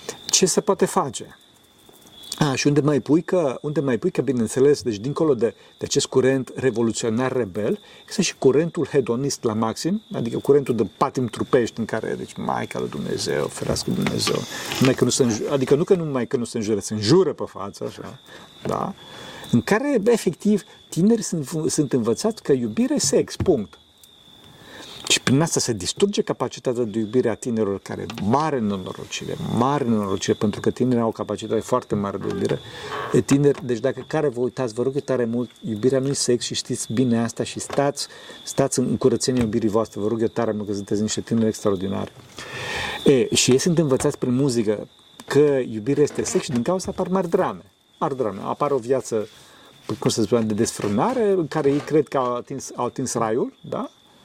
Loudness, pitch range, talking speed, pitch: -22 LUFS, 115-150 Hz, 190 wpm, 130 Hz